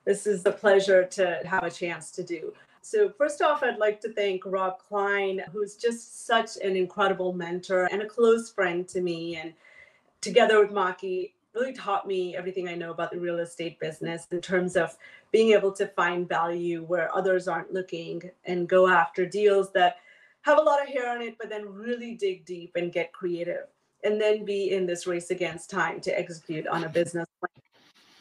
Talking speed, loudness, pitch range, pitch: 195 wpm, -27 LUFS, 175-215 Hz, 190 Hz